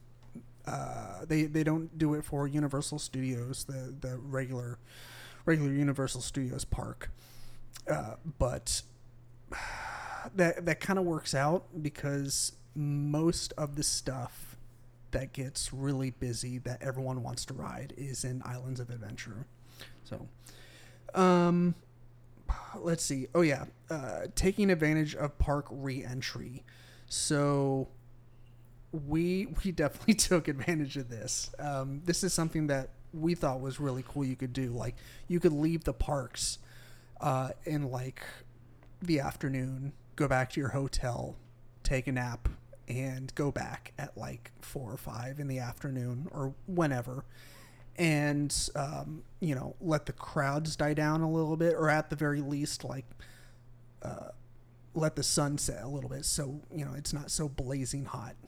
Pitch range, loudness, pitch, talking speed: 125-150 Hz, -33 LUFS, 135 Hz, 145 wpm